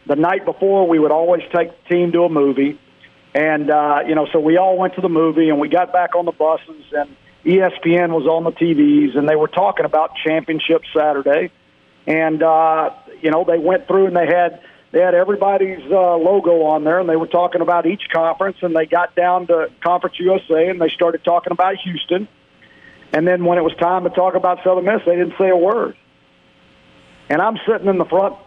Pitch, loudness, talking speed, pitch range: 175 Hz, -16 LUFS, 215 wpm, 160-185 Hz